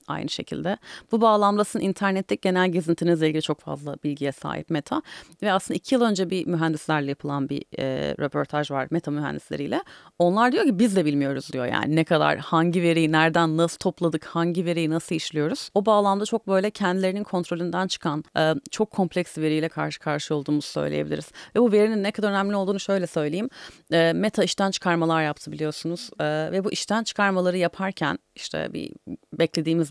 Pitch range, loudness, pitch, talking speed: 155-195 Hz, -24 LUFS, 170 Hz, 170 wpm